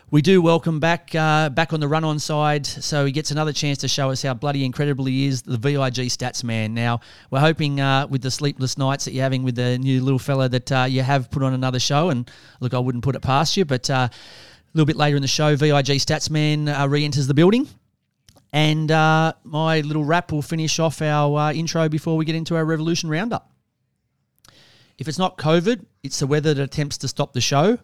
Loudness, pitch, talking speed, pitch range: -20 LUFS, 145 Hz, 235 wpm, 130-155 Hz